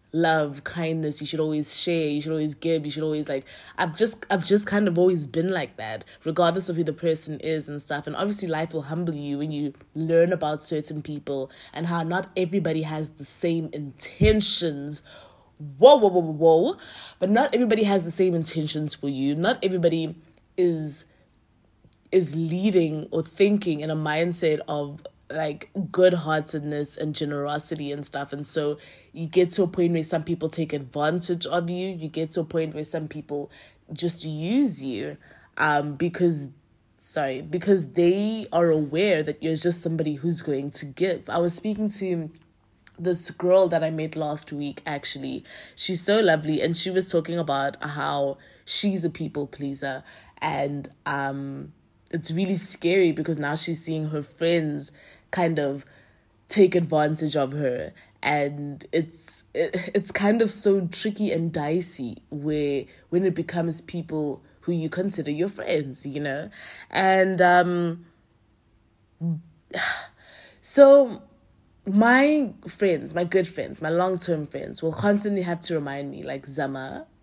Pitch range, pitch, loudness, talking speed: 150-180 Hz, 160 Hz, -24 LUFS, 160 wpm